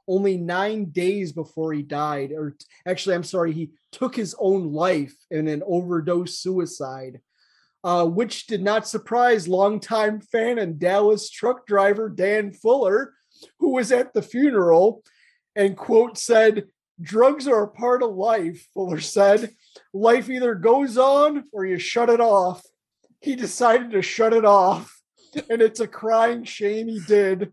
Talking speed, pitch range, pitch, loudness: 155 wpm, 180-235 Hz, 205 Hz, -21 LUFS